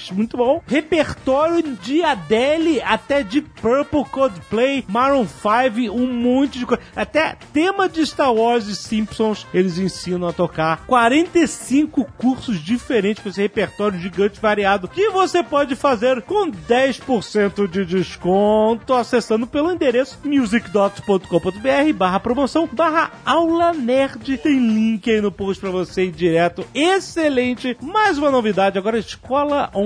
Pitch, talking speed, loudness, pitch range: 245 Hz, 135 wpm, -18 LUFS, 205-285 Hz